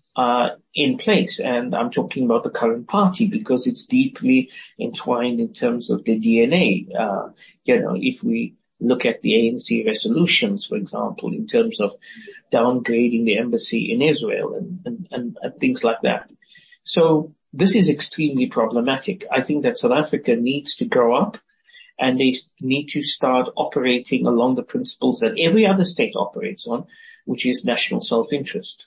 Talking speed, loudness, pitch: 165 wpm, -20 LUFS, 195 Hz